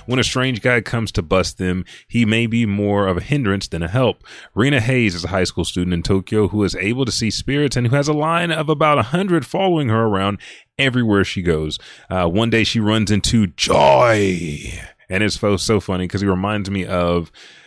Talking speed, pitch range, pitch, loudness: 220 wpm, 95-125 Hz, 105 Hz, -18 LUFS